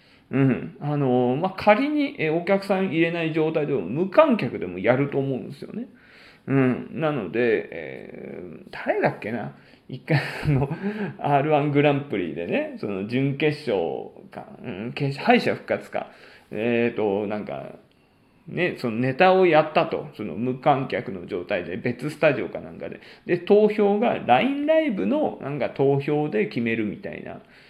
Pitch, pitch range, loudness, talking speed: 150 Hz, 130-190 Hz, -23 LUFS, 285 characters per minute